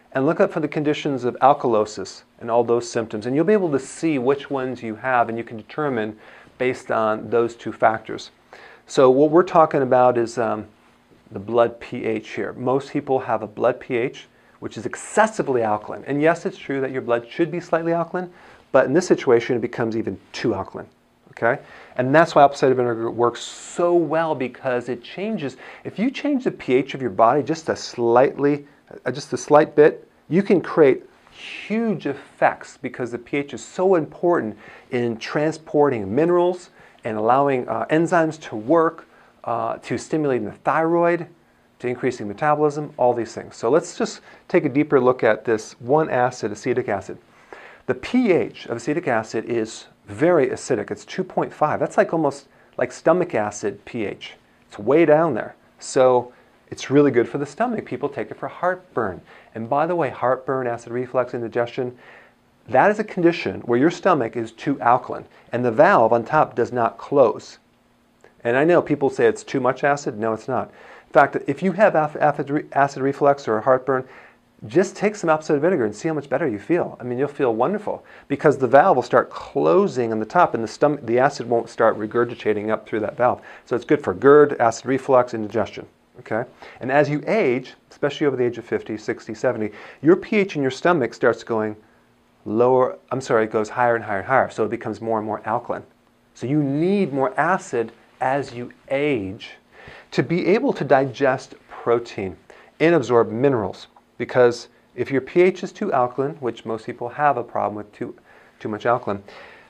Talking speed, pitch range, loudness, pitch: 190 wpm, 115-155 Hz, -21 LUFS, 130 Hz